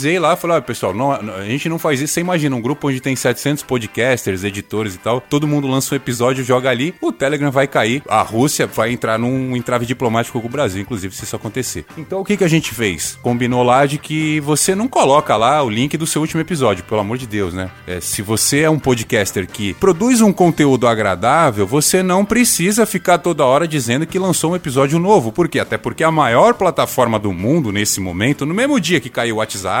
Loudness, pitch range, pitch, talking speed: -16 LUFS, 115-165 Hz, 135 Hz, 230 wpm